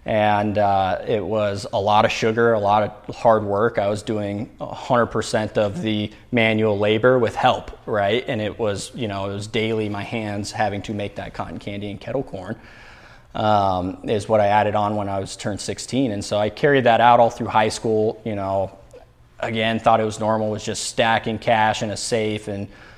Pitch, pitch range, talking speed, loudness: 105 Hz, 100-110 Hz, 210 wpm, -21 LUFS